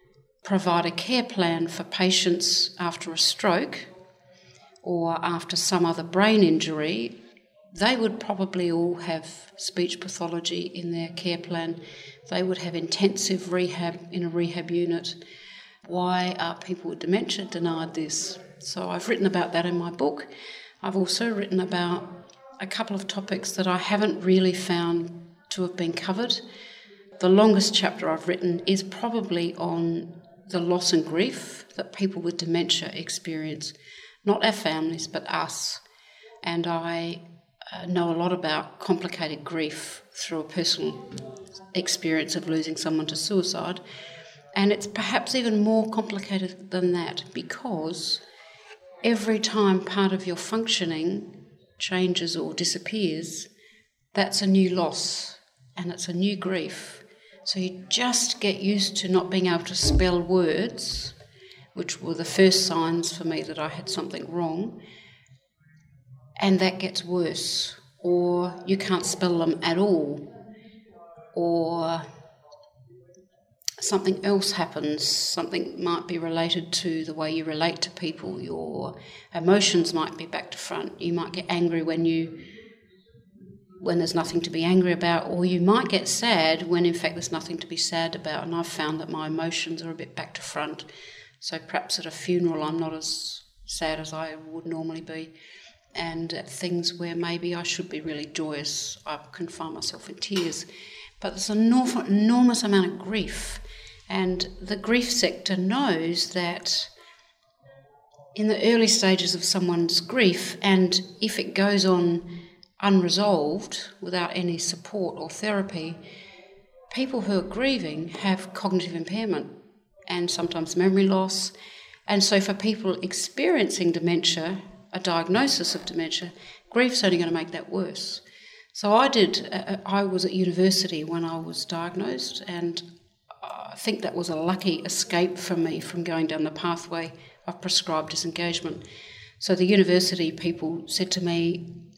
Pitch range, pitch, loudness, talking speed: 165-190 Hz, 175 Hz, -25 LUFS, 150 wpm